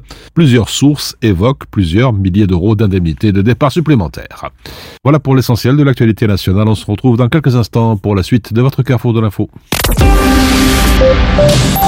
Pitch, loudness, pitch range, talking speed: 115 Hz, -11 LUFS, 105-130 Hz, 150 wpm